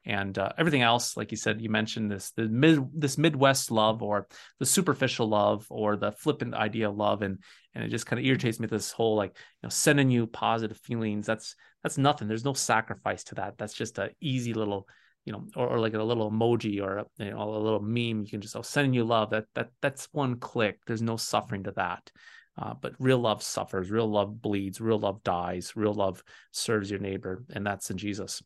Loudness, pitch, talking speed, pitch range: -29 LUFS, 110 Hz, 230 wpm, 105-120 Hz